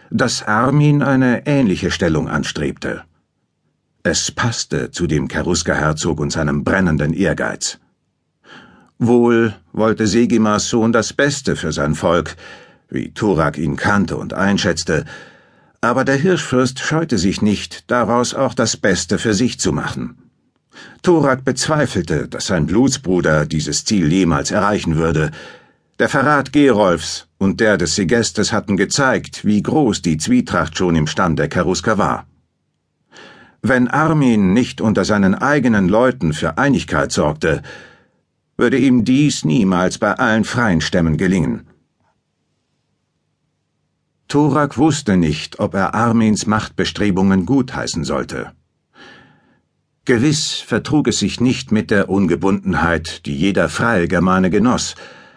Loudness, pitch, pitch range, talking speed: -16 LUFS, 110 Hz, 90-135 Hz, 120 wpm